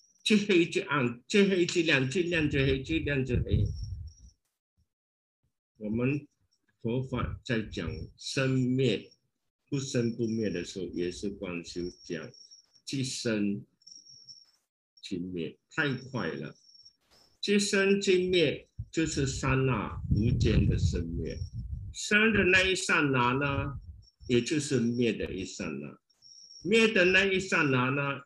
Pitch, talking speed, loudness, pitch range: 125 Hz, 170 characters per minute, -29 LUFS, 100-150 Hz